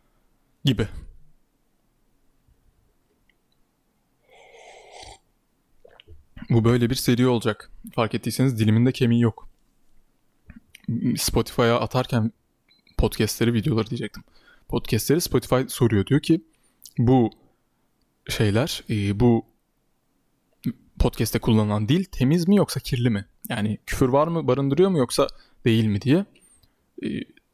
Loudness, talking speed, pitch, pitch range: -23 LUFS, 90 wpm, 120 Hz, 110-130 Hz